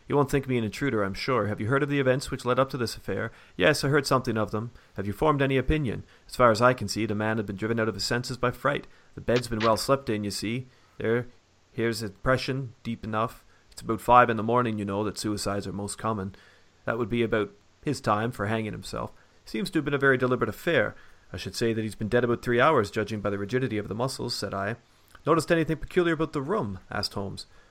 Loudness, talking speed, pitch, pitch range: -27 LUFS, 260 wpm, 115 Hz, 105-130 Hz